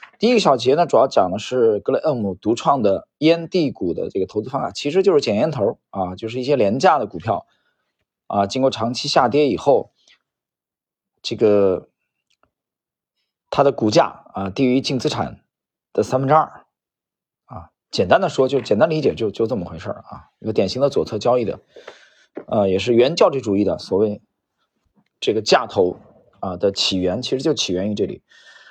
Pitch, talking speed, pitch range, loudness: 130 Hz, 270 characters per minute, 105-155 Hz, -19 LUFS